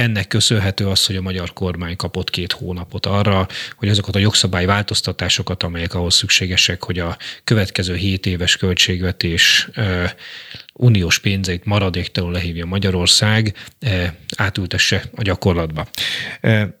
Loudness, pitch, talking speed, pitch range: -17 LUFS, 95 Hz, 125 wpm, 90-105 Hz